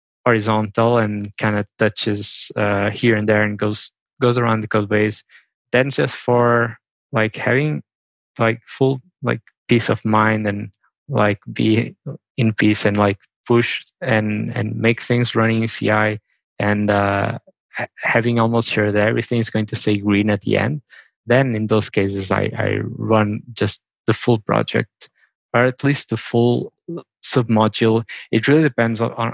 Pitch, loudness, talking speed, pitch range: 110 Hz, -19 LUFS, 165 wpm, 105-120 Hz